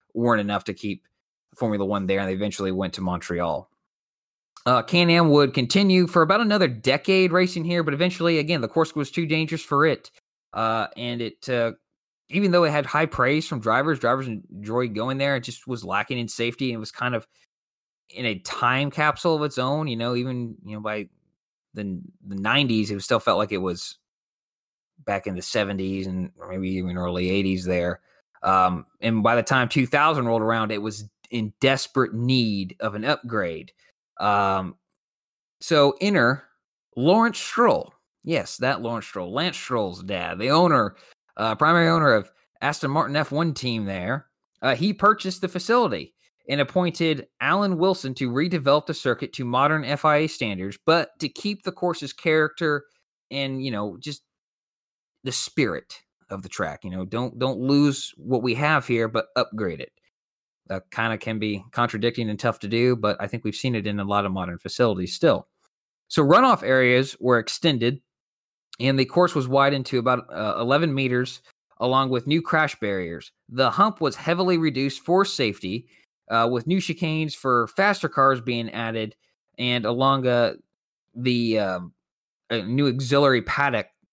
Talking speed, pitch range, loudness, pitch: 175 wpm, 110-150 Hz, -23 LUFS, 125 Hz